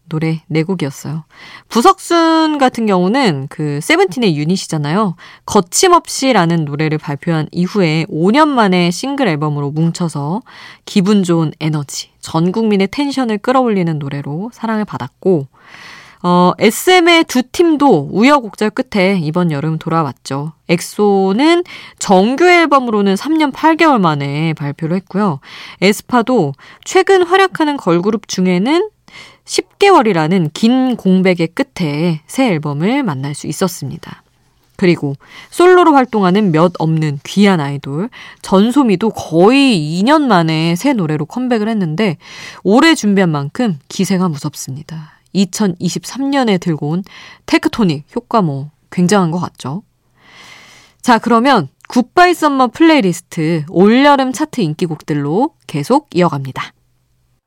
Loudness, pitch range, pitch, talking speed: -13 LUFS, 160-250 Hz, 190 Hz, 280 characters per minute